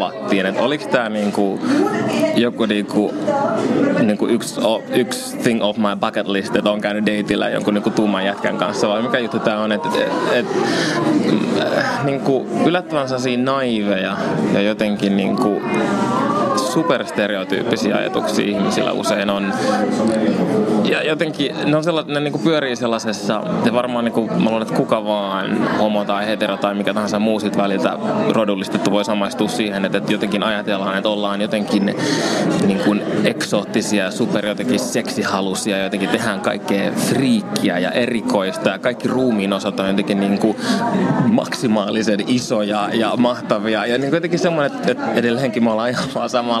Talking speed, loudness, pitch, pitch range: 150 wpm, -18 LUFS, 105 Hz, 100-120 Hz